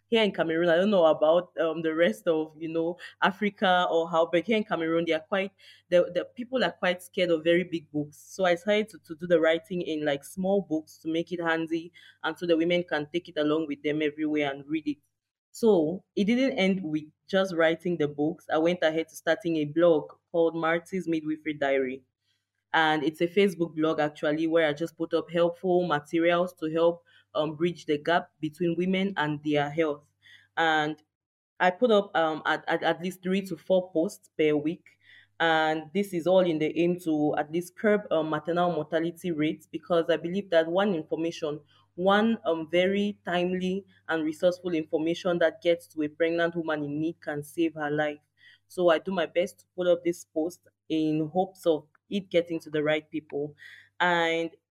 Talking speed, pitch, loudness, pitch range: 200 wpm, 165 Hz, -27 LUFS, 155-180 Hz